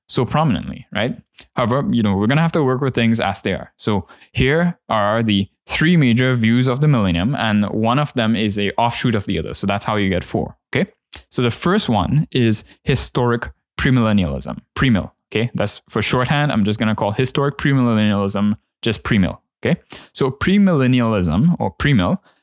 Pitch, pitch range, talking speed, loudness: 115 Hz, 100-130 Hz, 185 wpm, -18 LUFS